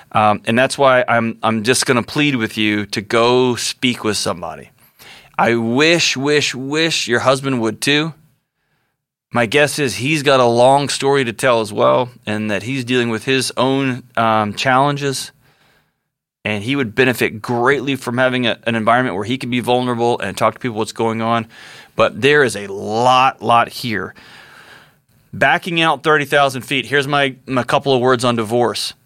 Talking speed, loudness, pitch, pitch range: 180 wpm, -16 LUFS, 125 Hz, 115-135 Hz